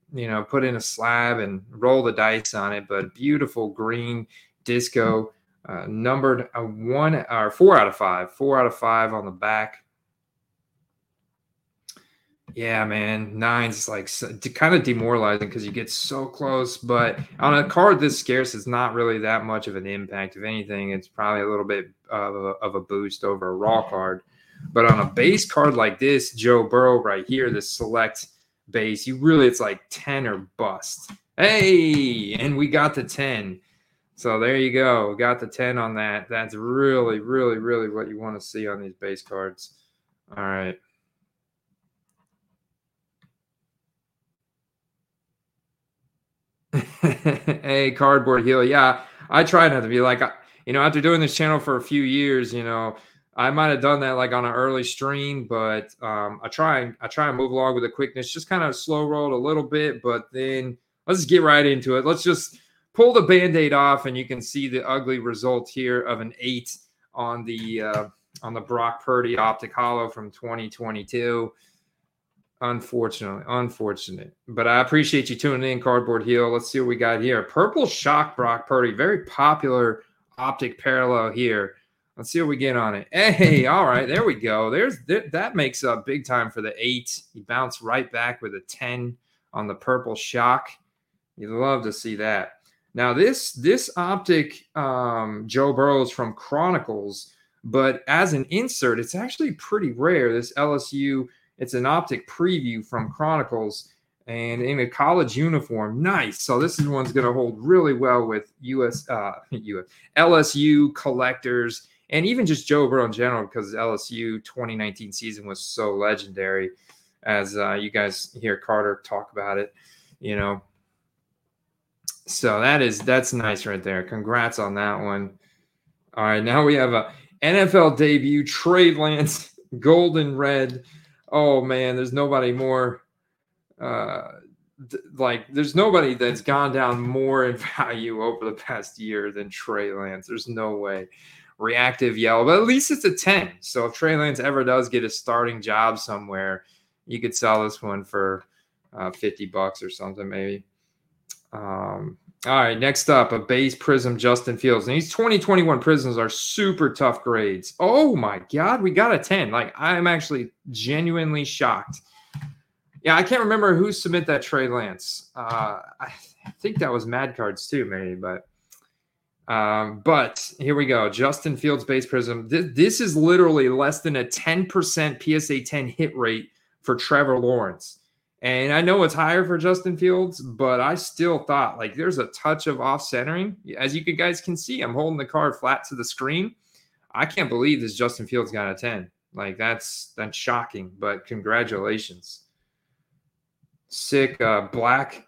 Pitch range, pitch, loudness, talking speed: 115-150 Hz, 130 Hz, -22 LUFS, 170 wpm